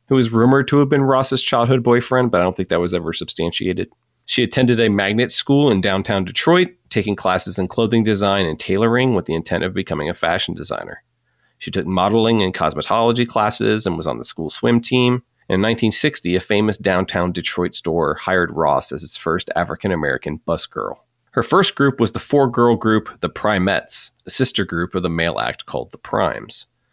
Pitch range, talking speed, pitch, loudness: 90-125 Hz, 195 wpm, 110 Hz, -18 LUFS